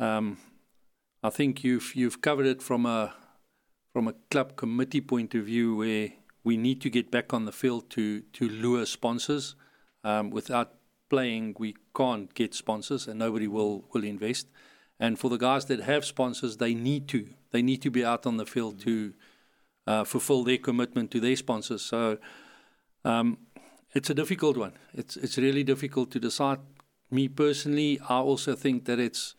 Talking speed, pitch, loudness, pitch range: 175 wpm, 125 Hz, -29 LUFS, 115-135 Hz